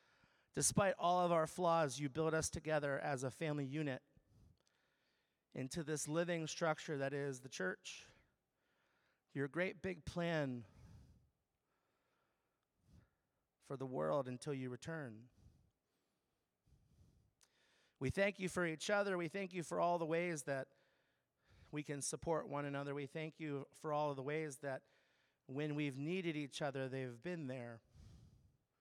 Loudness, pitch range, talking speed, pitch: -42 LUFS, 135-165 Hz, 140 wpm, 150 Hz